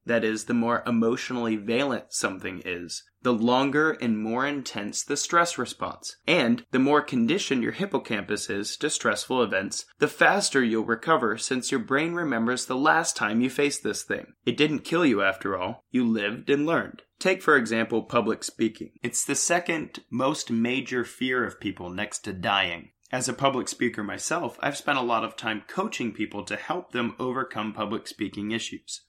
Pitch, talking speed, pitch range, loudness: 120 Hz, 180 wpm, 115-135 Hz, -26 LUFS